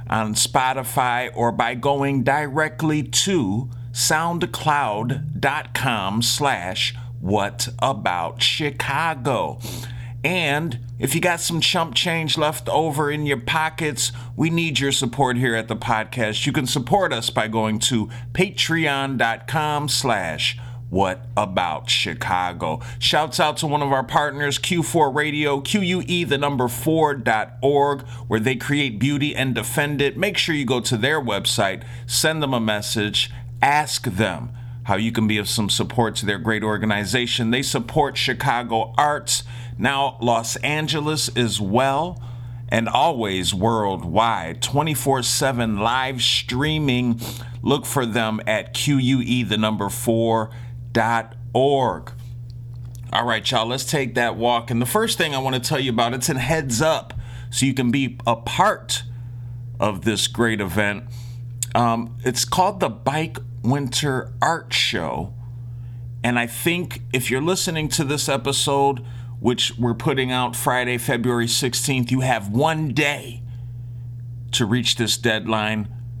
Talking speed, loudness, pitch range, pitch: 135 wpm, -21 LUFS, 120-140 Hz, 125 Hz